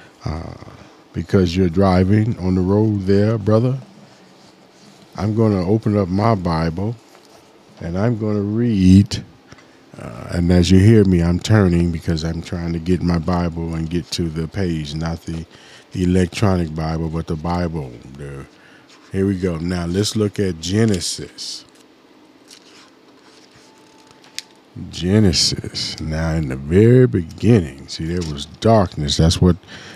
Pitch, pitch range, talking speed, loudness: 90 Hz, 85-105 Hz, 140 wpm, -18 LUFS